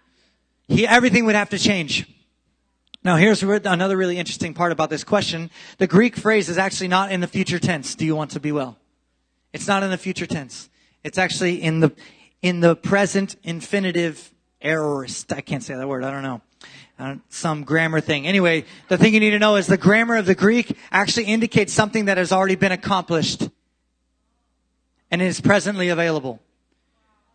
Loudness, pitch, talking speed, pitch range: -20 LUFS, 180 Hz, 185 wpm, 155-200 Hz